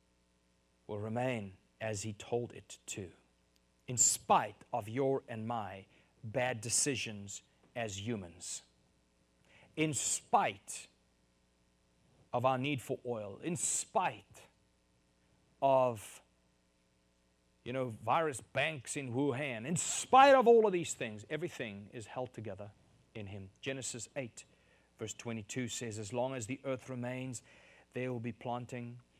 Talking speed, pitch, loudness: 125 wpm, 115 Hz, -35 LUFS